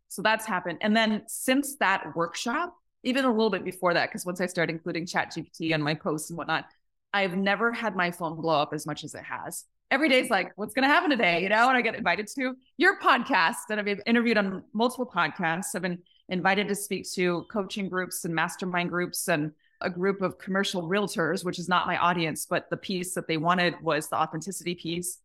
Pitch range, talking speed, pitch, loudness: 170-220 Hz, 220 wpm, 185 Hz, -27 LUFS